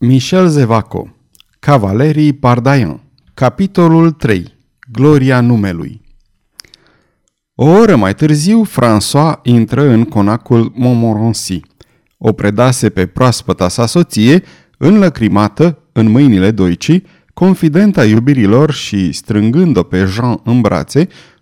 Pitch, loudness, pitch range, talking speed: 120 Hz, -10 LUFS, 105-150 Hz, 100 wpm